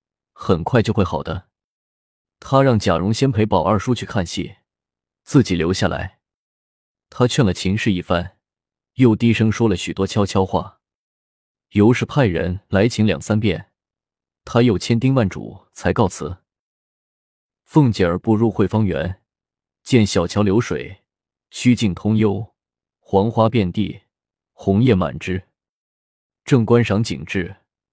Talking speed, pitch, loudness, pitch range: 190 characters per minute, 100 Hz, -19 LUFS, 90-115 Hz